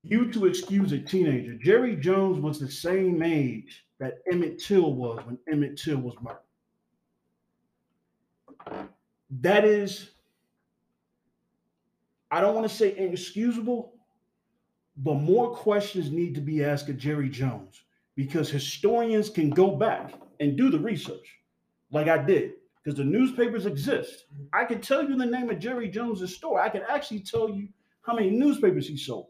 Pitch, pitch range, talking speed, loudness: 185 Hz, 145-220 Hz, 150 wpm, -26 LUFS